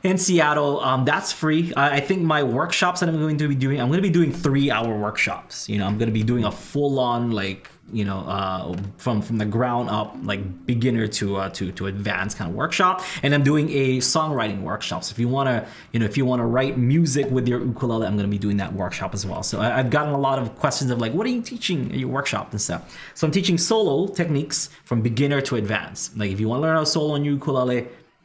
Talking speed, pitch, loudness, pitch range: 245 wpm, 125 Hz, -22 LUFS, 105-150 Hz